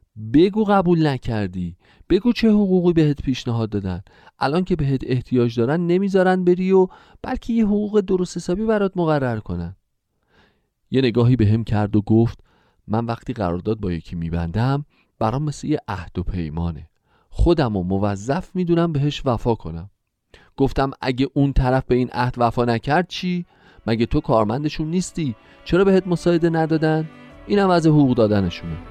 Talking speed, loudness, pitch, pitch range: 150 wpm, -20 LUFS, 130 Hz, 110-170 Hz